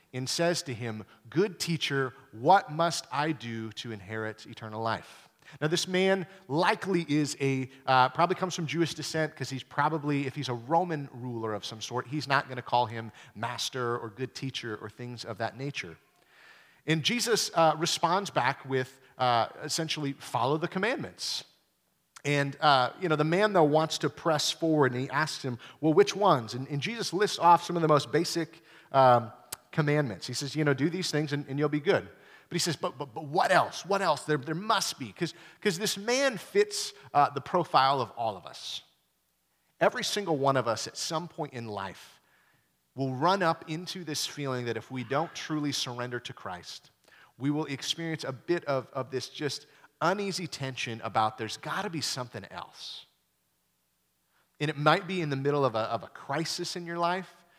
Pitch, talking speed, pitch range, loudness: 145 Hz, 195 wpm, 125-170 Hz, -29 LUFS